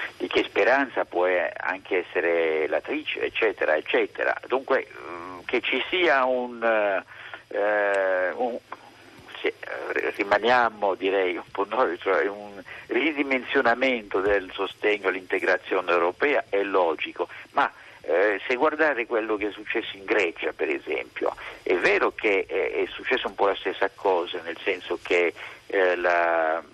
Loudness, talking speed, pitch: -25 LUFS, 130 wpm, 145 Hz